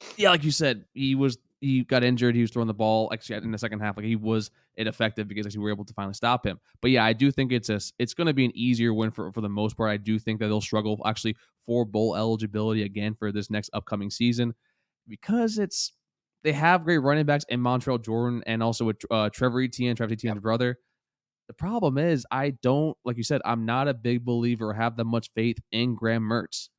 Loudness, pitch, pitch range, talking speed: -26 LUFS, 115 Hz, 110-125 Hz, 235 wpm